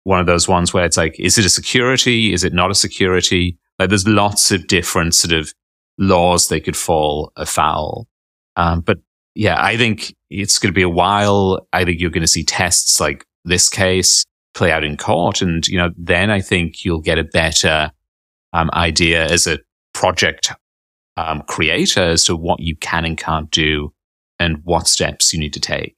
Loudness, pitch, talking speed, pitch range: -15 LUFS, 85 Hz, 195 wpm, 80-95 Hz